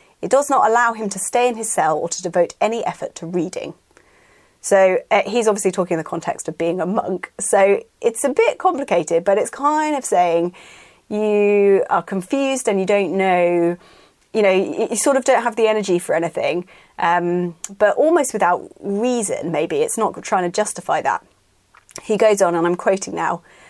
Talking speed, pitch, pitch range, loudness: 195 wpm, 200 Hz, 175-240 Hz, -18 LUFS